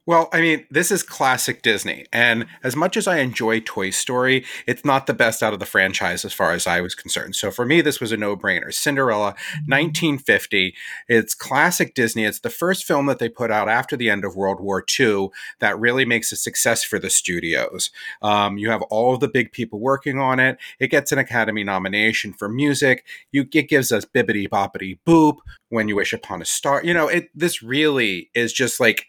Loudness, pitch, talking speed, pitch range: -19 LUFS, 120 Hz, 215 wpm, 105-145 Hz